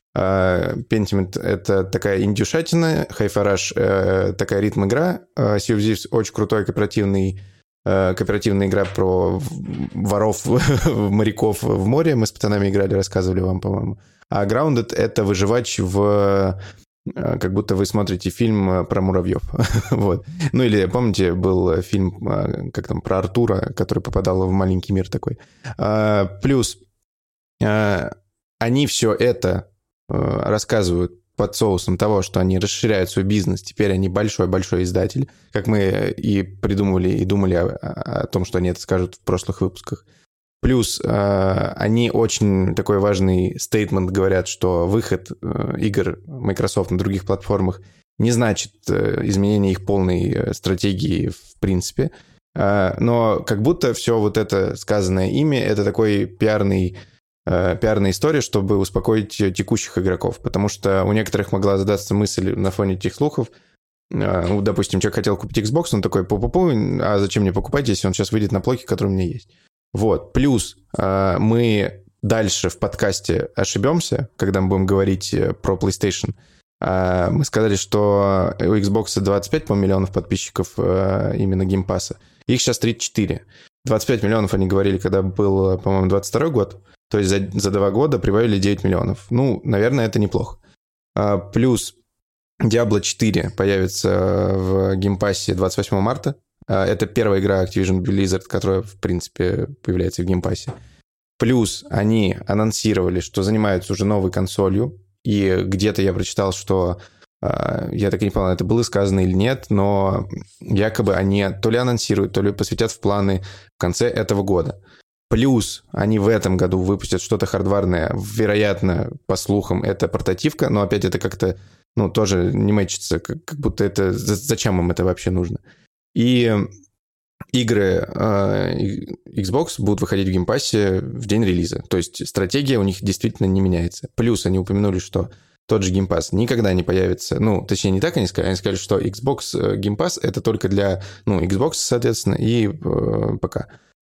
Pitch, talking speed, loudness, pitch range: 100 Hz, 145 wpm, -20 LUFS, 95-110 Hz